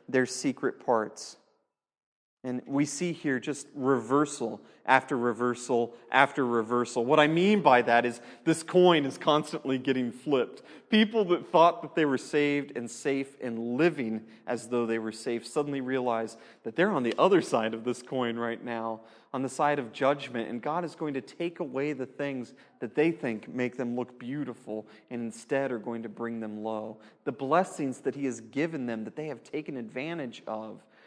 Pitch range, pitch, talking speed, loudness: 115-145 Hz, 130 Hz, 185 wpm, -29 LUFS